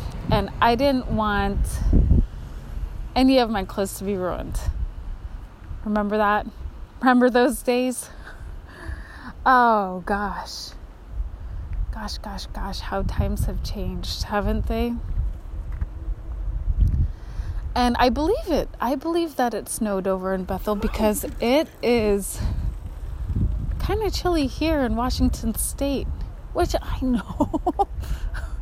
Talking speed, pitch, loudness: 110 wpm, 200 Hz, -24 LUFS